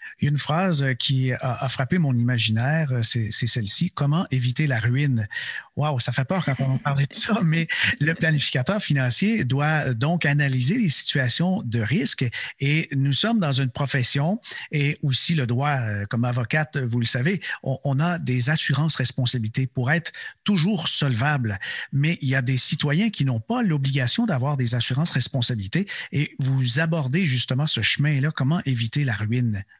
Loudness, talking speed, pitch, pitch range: -21 LUFS, 170 wpm, 140 Hz, 125-160 Hz